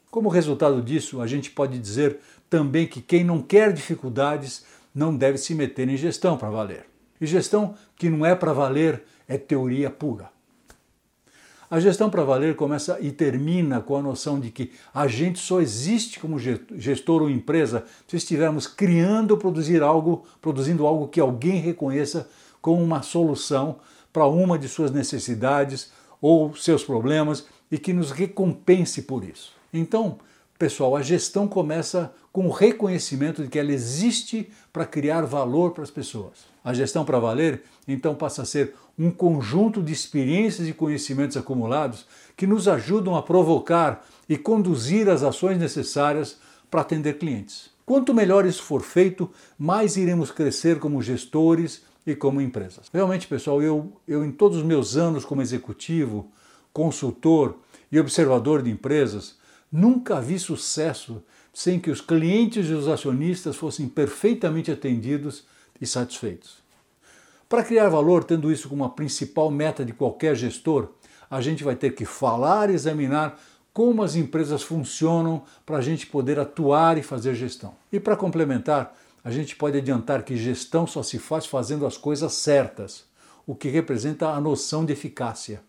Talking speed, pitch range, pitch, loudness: 155 wpm, 140-170 Hz, 155 Hz, -23 LUFS